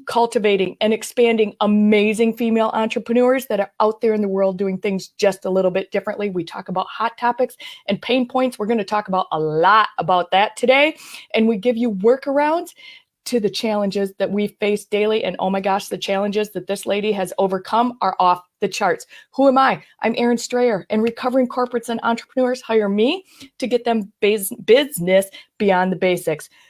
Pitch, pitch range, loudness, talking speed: 215 Hz, 195-245 Hz, -19 LUFS, 195 wpm